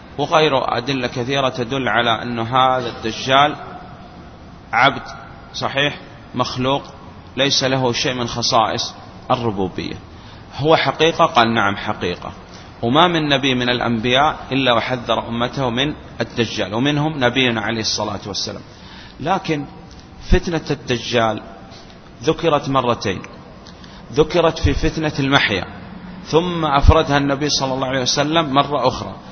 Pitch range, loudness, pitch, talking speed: 115-145 Hz, -18 LUFS, 130 Hz, 115 wpm